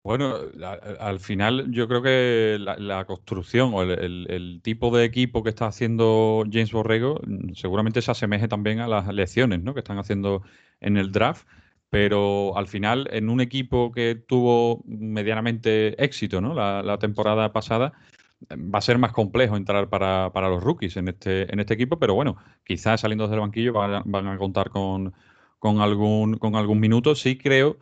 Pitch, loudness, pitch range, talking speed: 110 Hz, -23 LUFS, 100-120 Hz, 180 wpm